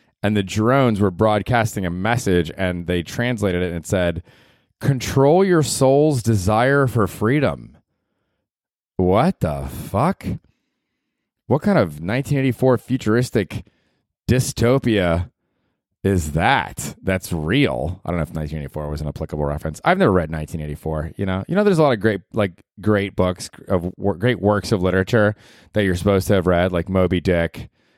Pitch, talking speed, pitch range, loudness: 100 Hz, 155 wpm, 85-120 Hz, -20 LUFS